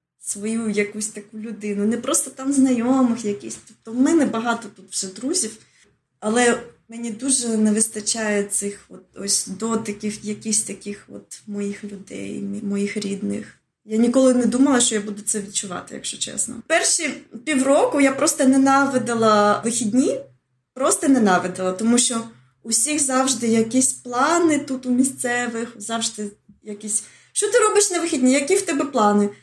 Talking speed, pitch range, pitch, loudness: 145 wpm, 210-265 Hz, 230 Hz, -20 LUFS